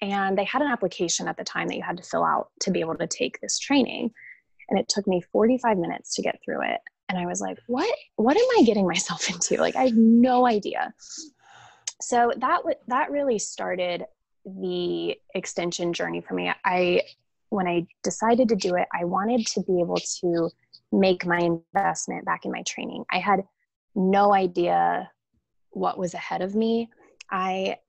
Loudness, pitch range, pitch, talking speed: -25 LUFS, 180-245 Hz, 195 Hz, 190 wpm